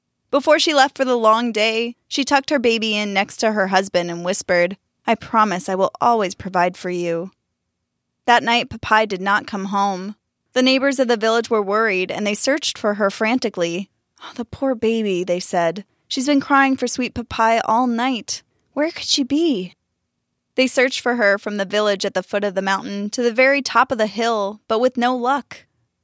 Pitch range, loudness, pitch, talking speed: 195-255 Hz, -19 LUFS, 220 Hz, 205 wpm